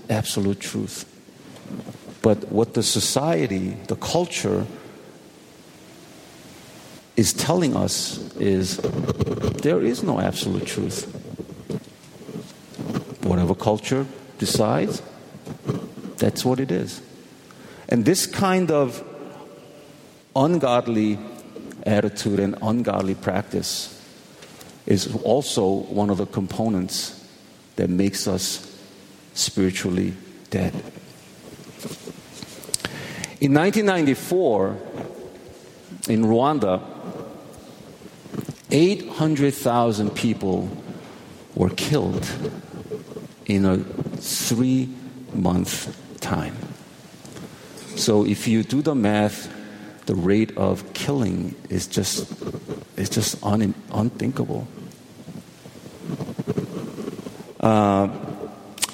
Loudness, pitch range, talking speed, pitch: -23 LUFS, 100-135 Hz, 75 wpm, 110 Hz